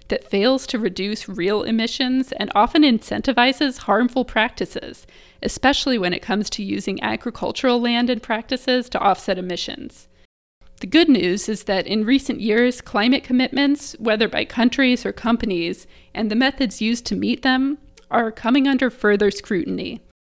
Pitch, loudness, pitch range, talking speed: 235 Hz, -20 LUFS, 205-260 Hz, 150 wpm